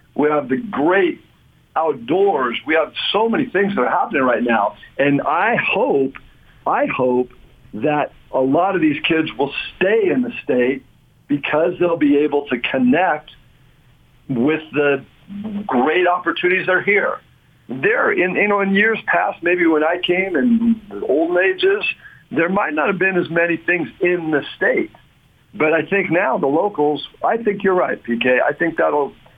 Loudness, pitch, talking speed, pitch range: -18 LUFS, 165 Hz, 170 wpm, 145-200 Hz